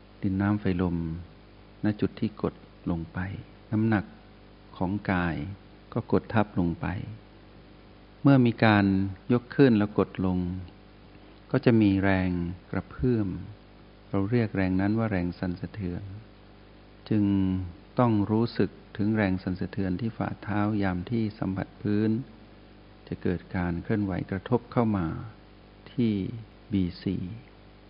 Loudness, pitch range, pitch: -28 LUFS, 95-105 Hz, 105 Hz